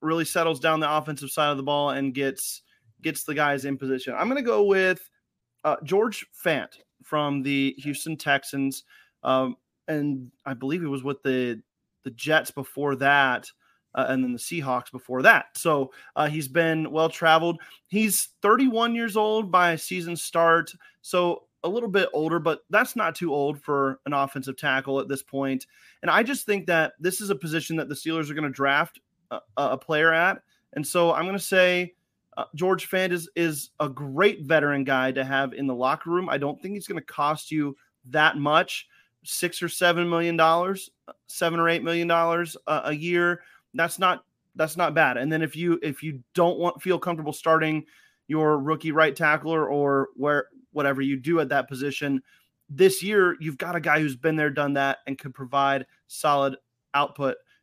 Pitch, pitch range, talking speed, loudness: 155 Hz, 140-170 Hz, 190 wpm, -24 LUFS